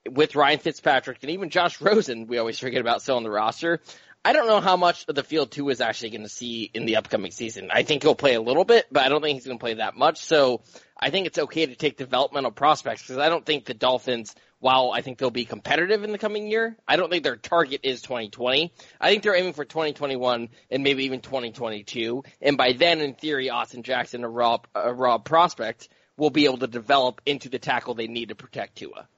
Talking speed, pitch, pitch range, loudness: 240 wpm, 130 Hz, 120-155 Hz, -23 LUFS